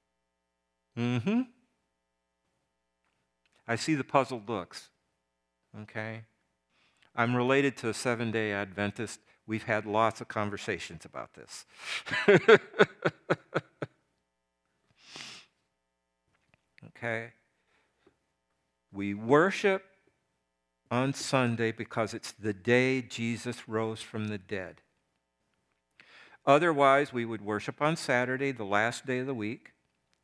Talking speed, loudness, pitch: 95 wpm, -29 LUFS, 110 Hz